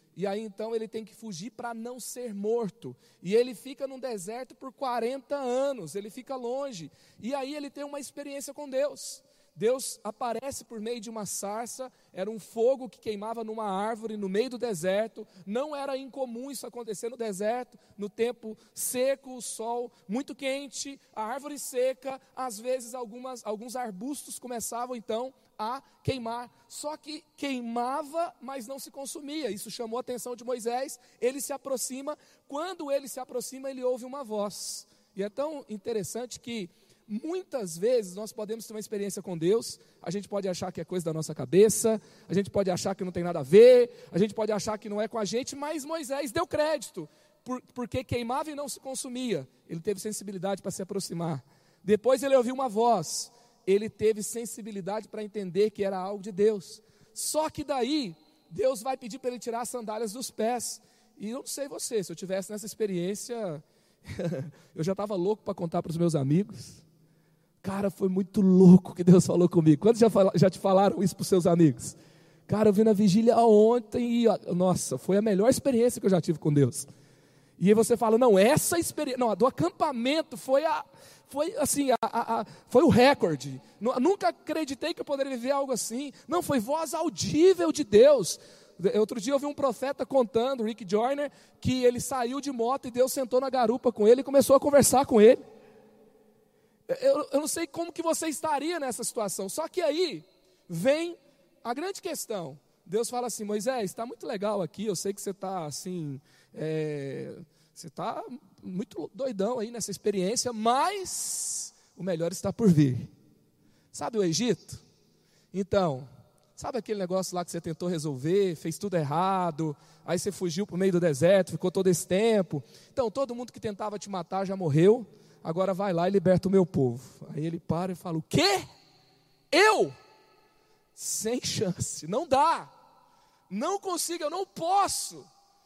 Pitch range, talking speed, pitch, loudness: 190-265 Hz, 180 wpm, 225 Hz, -28 LUFS